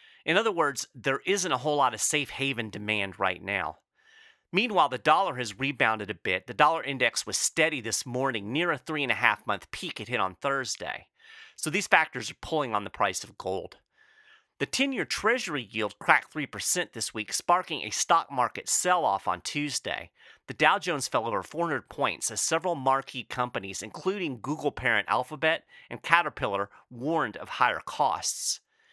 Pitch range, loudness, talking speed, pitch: 110-160 Hz, -28 LUFS, 185 wpm, 135 Hz